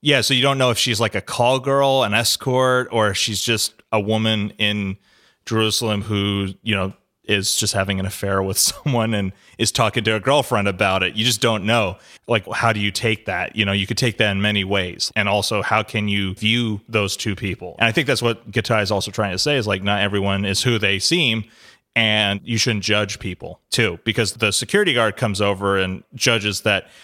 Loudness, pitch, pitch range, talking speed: -19 LUFS, 110 Hz, 100-115 Hz, 225 wpm